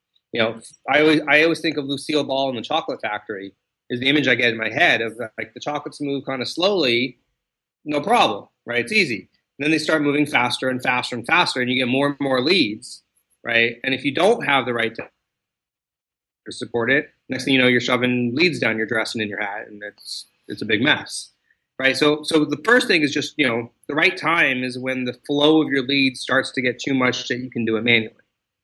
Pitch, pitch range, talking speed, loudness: 130 Hz, 120-145 Hz, 240 wpm, -20 LUFS